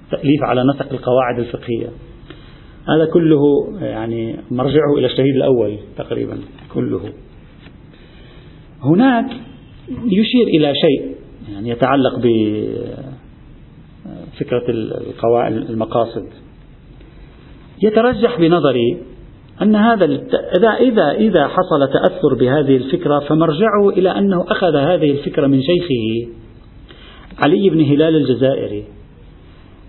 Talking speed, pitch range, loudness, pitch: 90 wpm, 120-170 Hz, -15 LUFS, 140 Hz